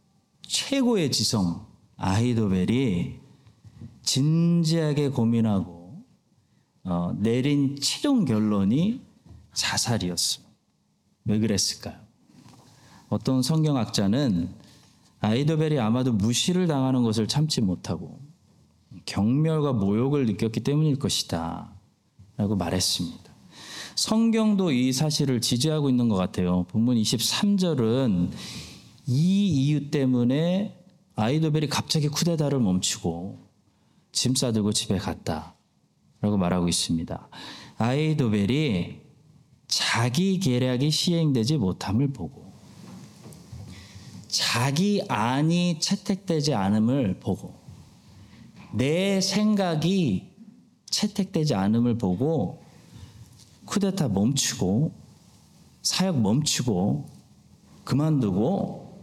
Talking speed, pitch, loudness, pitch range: 210 characters per minute, 130 Hz, -24 LUFS, 105-160 Hz